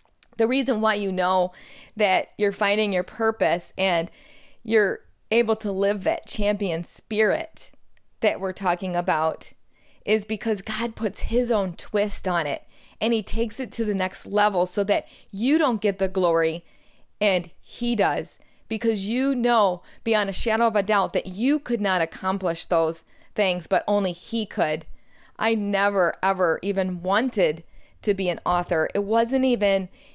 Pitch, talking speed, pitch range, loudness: 205 Hz, 160 wpm, 185-225 Hz, -24 LUFS